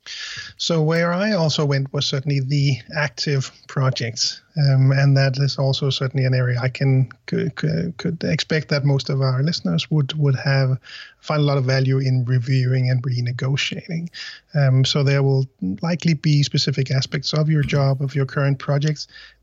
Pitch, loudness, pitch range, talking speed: 140 Hz, -20 LUFS, 135-155 Hz, 170 wpm